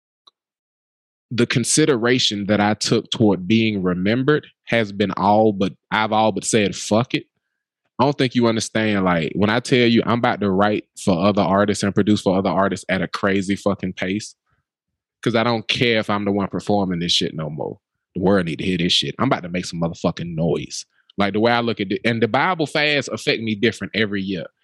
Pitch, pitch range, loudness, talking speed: 105 Hz, 100-115 Hz, -19 LUFS, 215 wpm